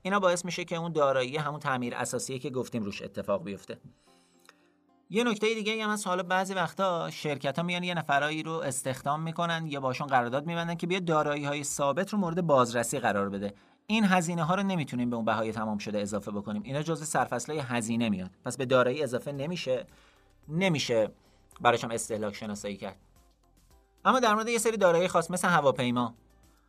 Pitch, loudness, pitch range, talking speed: 145 Hz, -29 LUFS, 120-175 Hz, 180 wpm